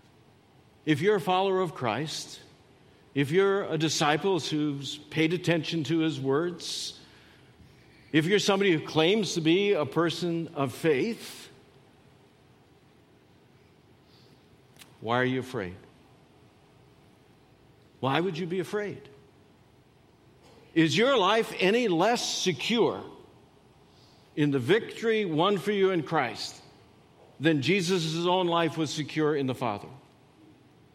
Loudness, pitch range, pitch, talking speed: -27 LUFS, 140-185 Hz, 160 Hz, 115 wpm